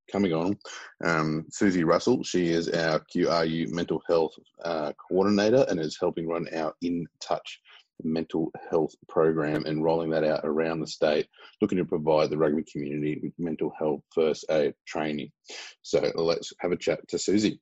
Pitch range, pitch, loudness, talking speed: 80-85 Hz, 80 Hz, -27 LUFS, 165 wpm